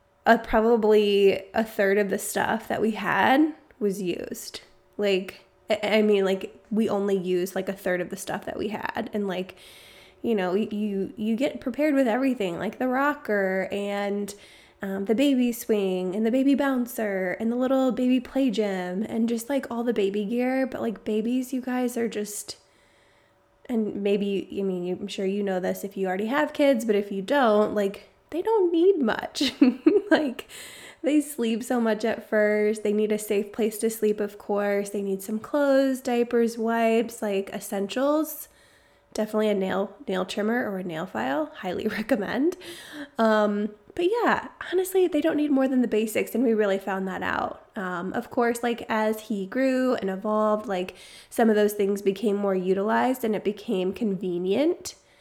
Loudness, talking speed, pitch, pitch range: -25 LUFS, 180 wpm, 215 Hz, 200-255 Hz